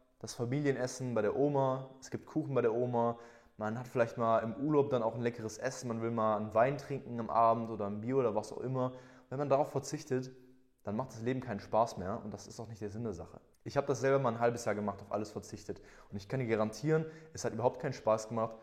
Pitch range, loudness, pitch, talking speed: 110-130 Hz, -35 LUFS, 120 Hz, 260 wpm